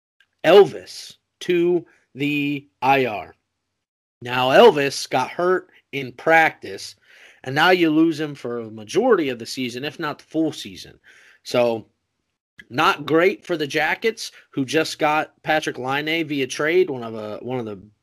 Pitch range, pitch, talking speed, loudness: 120-160 Hz, 140 Hz, 150 wpm, -20 LUFS